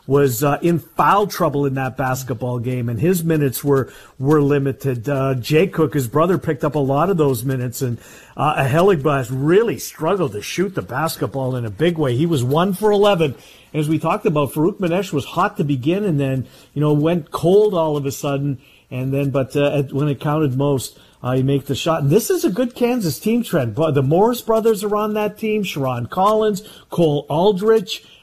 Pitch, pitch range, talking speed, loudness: 150 Hz, 135-180 Hz, 210 wpm, -18 LUFS